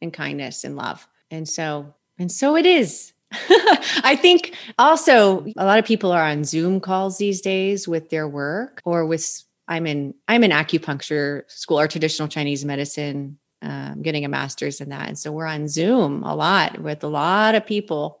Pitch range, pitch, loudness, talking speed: 150-210 Hz, 165 Hz, -19 LUFS, 185 wpm